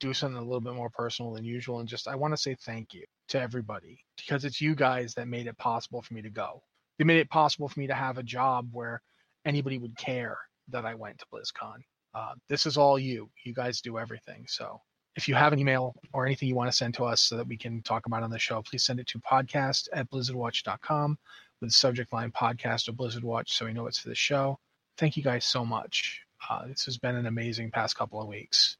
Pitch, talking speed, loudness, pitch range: 125 Hz, 245 wpm, -30 LUFS, 115-135 Hz